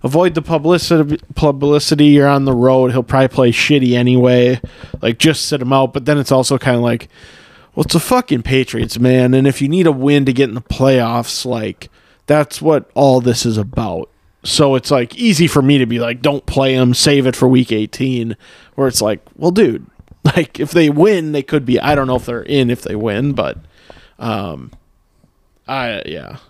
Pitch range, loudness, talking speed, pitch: 125-150 Hz, -14 LUFS, 205 wpm, 135 Hz